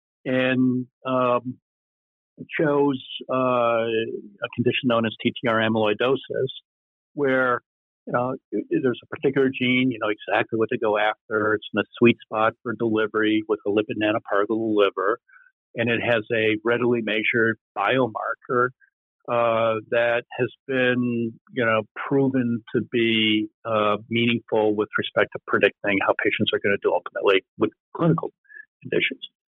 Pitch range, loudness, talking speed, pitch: 110-125 Hz, -23 LUFS, 140 wpm, 115 Hz